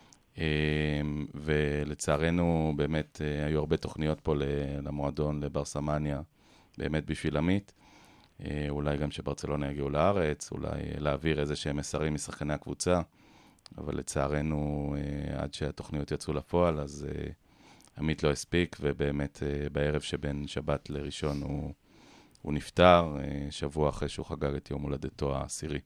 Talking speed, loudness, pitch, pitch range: 115 wpm, -32 LUFS, 75 Hz, 70-75 Hz